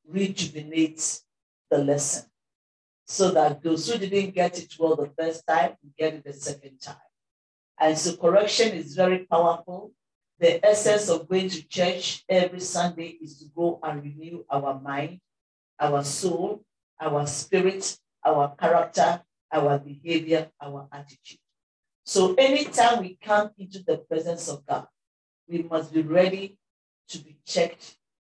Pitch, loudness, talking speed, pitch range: 165 Hz, -25 LUFS, 140 wpm, 150-185 Hz